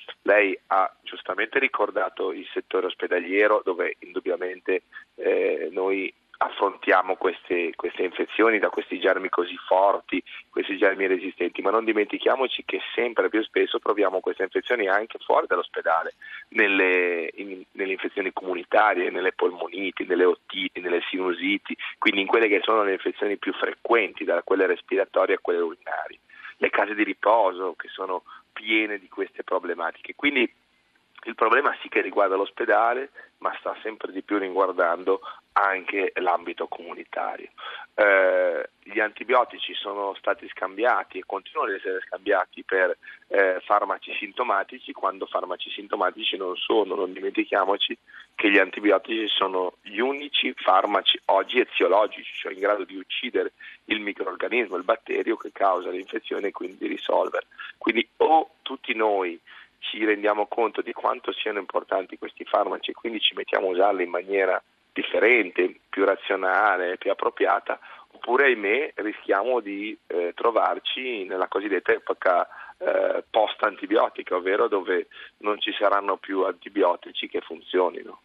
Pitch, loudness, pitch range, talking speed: 400 Hz, -24 LUFS, 350-440 Hz, 140 wpm